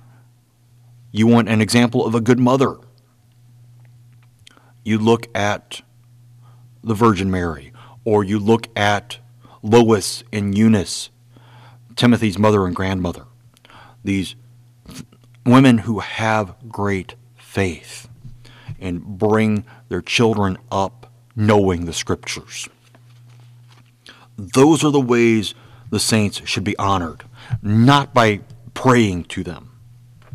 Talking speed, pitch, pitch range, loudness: 105 wpm, 120 Hz, 105-120 Hz, -18 LUFS